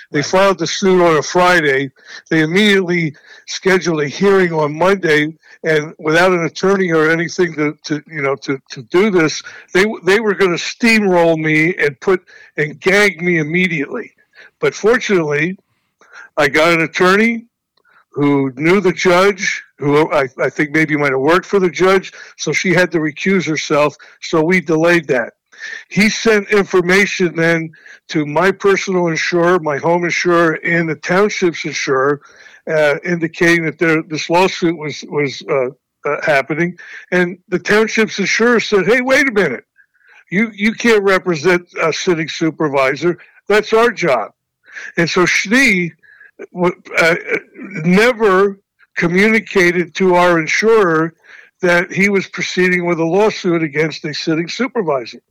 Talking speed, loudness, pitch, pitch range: 150 wpm, -14 LUFS, 175 Hz, 160-195 Hz